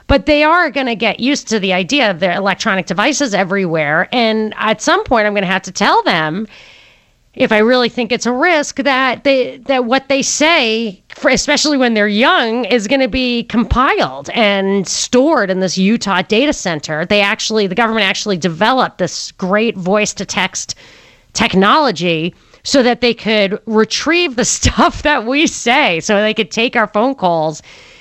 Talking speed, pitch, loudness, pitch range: 180 wpm, 220 Hz, -13 LUFS, 195-260 Hz